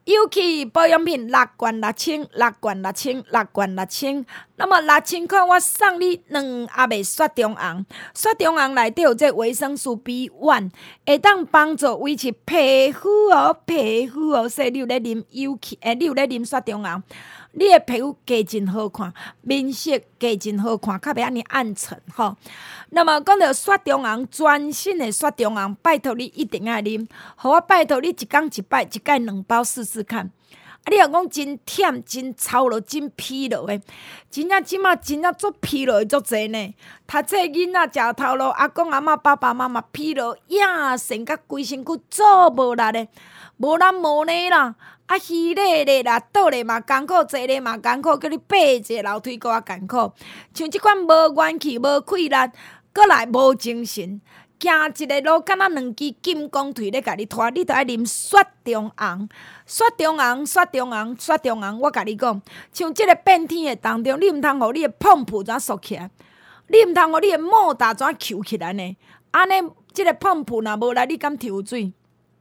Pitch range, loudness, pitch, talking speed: 230-325 Hz, -19 LUFS, 270 Hz, 255 characters per minute